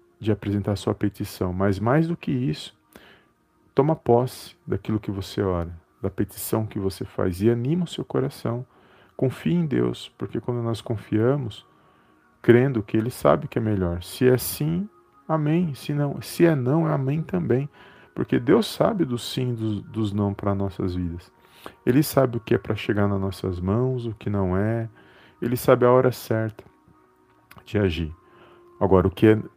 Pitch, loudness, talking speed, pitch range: 110 Hz, -24 LUFS, 180 wpm, 100-130 Hz